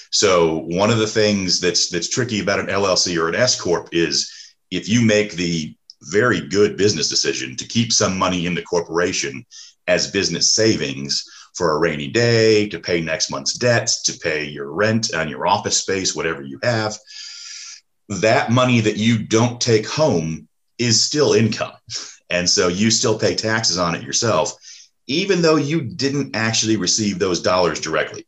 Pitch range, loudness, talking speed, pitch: 85-120 Hz, -18 LUFS, 175 wpm, 110 Hz